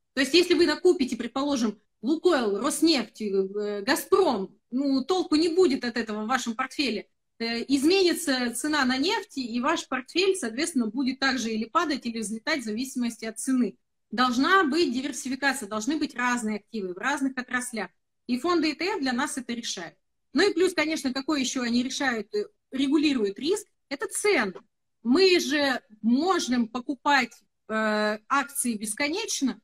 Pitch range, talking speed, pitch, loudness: 235-310 Hz, 145 wpm, 265 Hz, -26 LUFS